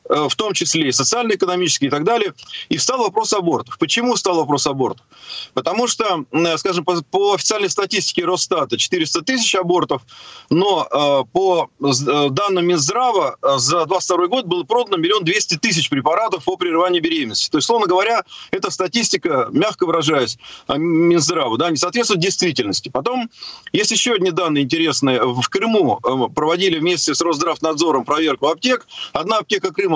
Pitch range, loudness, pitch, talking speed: 160-230 Hz, -17 LUFS, 180 Hz, 145 wpm